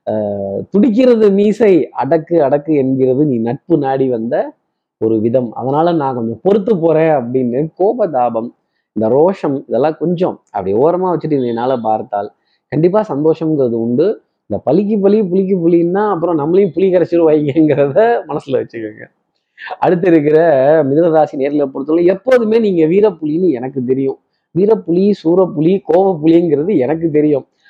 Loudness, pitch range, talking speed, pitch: -13 LUFS, 130-180 Hz, 125 wpm, 160 Hz